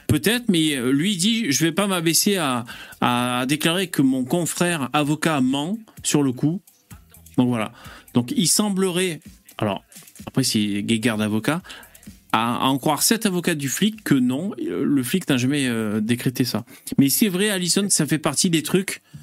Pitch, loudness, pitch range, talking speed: 150 Hz, -21 LUFS, 125-185 Hz, 170 wpm